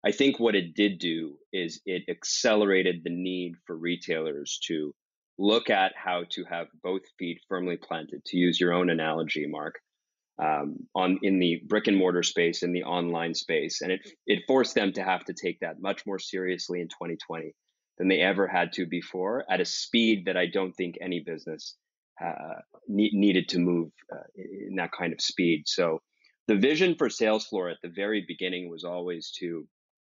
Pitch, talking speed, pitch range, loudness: 90 Hz, 190 wpm, 85-100 Hz, -28 LUFS